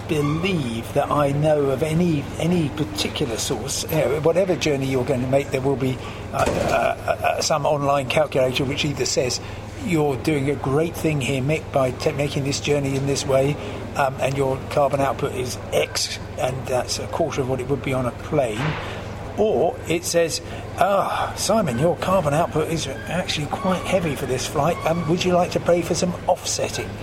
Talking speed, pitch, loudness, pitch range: 200 wpm, 140 Hz, -22 LUFS, 130-155 Hz